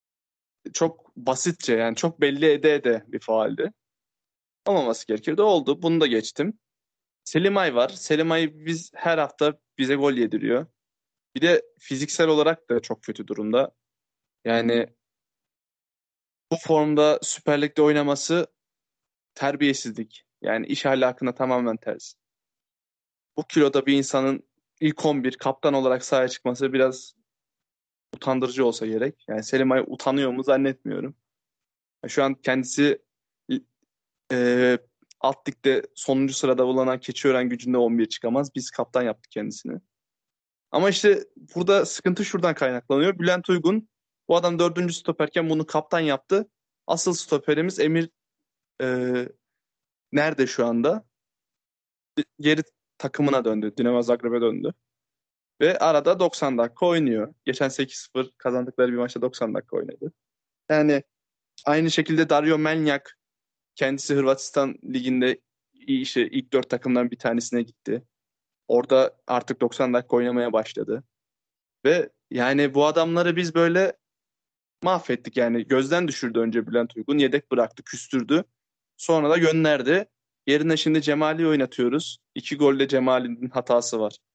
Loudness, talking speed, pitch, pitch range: -23 LUFS, 120 wpm, 135 Hz, 125-160 Hz